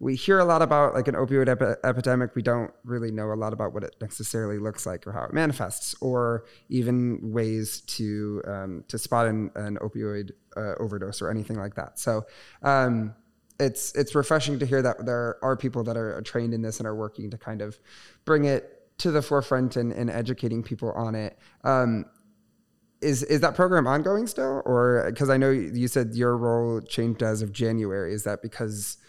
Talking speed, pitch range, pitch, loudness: 200 wpm, 110-130 Hz, 115 Hz, -26 LUFS